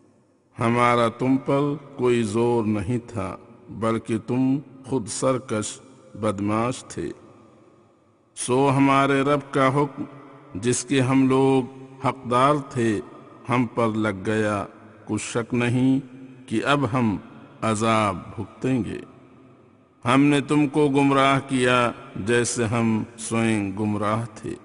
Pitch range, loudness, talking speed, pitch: 110-135 Hz, -23 LUFS, 115 wpm, 120 Hz